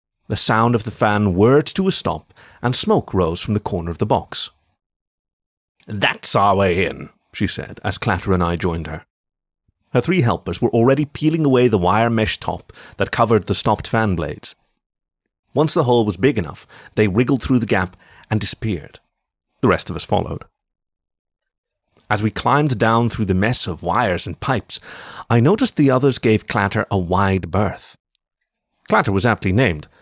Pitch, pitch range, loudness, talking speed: 110 Hz, 95-120 Hz, -18 LUFS, 180 wpm